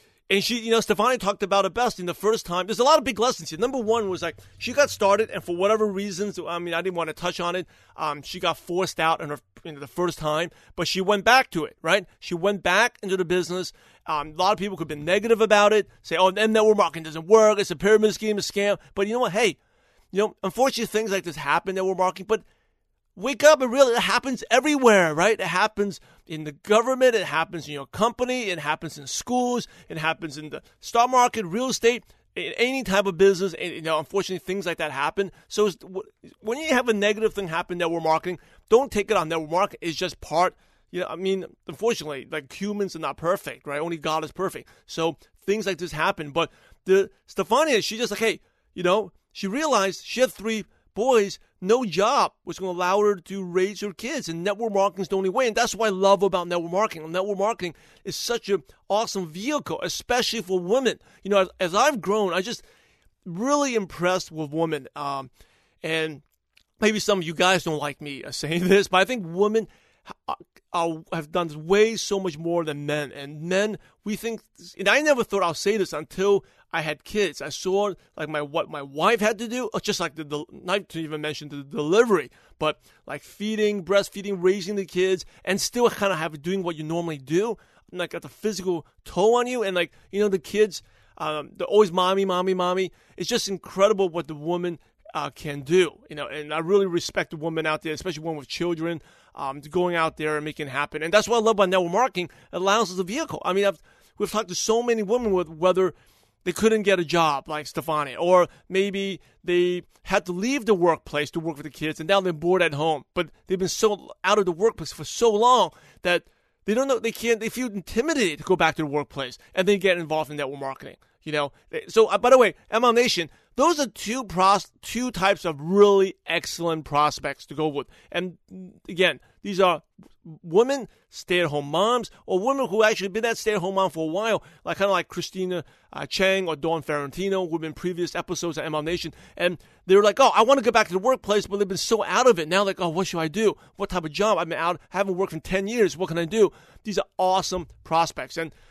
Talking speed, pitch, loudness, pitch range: 230 wpm, 185 Hz, -24 LUFS, 165-210 Hz